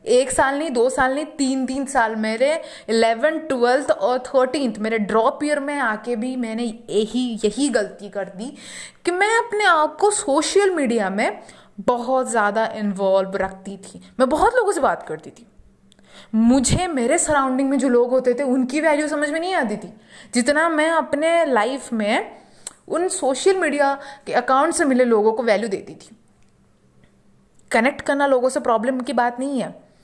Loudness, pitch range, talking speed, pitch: -20 LUFS, 230-300 Hz, 175 wpm, 260 Hz